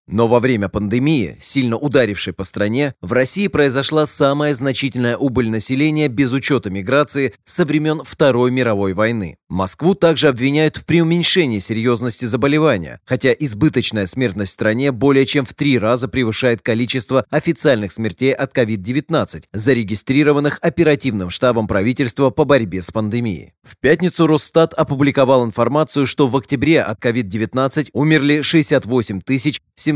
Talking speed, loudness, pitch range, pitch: 135 wpm, -16 LUFS, 115-150 Hz, 135 Hz